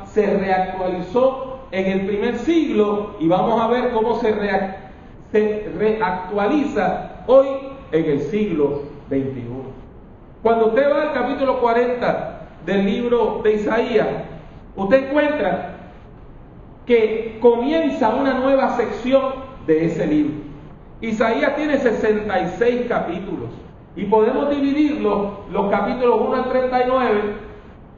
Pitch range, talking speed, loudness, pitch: 190-260 Hz, 105 wpm, -19 LUFS, 225 Hz